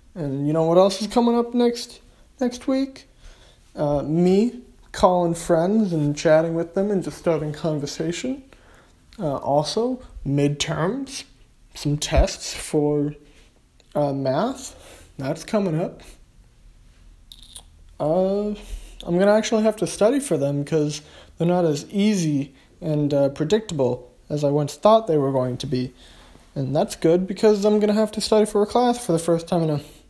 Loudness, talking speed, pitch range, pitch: -22 LUFS, 155 wpm, 145-210 Hz, 165 Hz